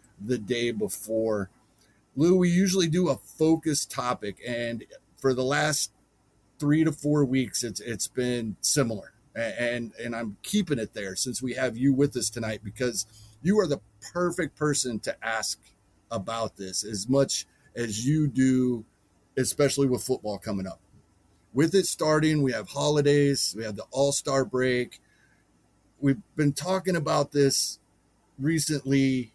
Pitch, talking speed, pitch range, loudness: 130 Hz, 145 wpm, 110-145 Hz, -27 LUFS